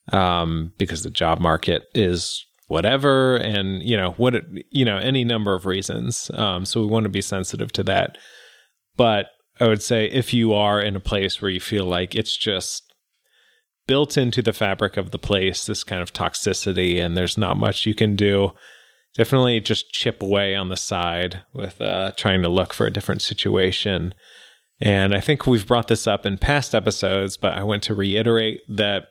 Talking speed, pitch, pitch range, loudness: 190 wpm, 100 Hz, 95-115 Hz, -21 LUFS